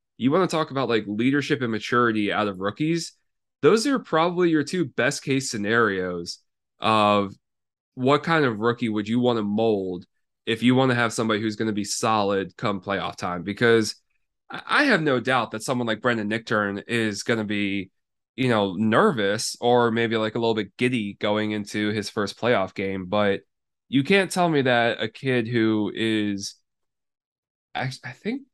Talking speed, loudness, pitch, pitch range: 180 wpm, -23 LUFS, 115 Hz, 105-130 Hz